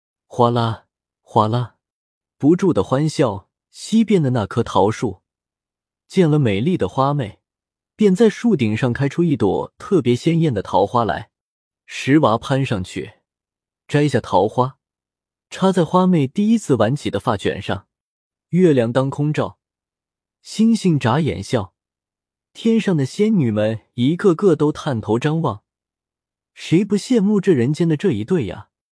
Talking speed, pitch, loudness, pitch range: 205 characters per minute, 135 Hz, -18 LUFS, 110-180 Hz